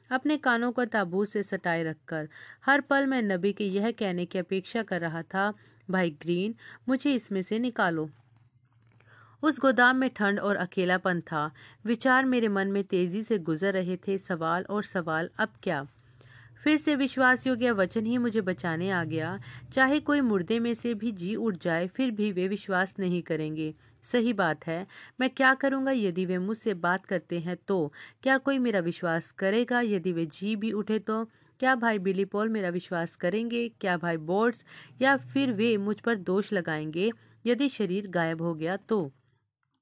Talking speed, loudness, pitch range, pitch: 175 wpm, -28 LUFS, 175-235 Hz, 195 Hz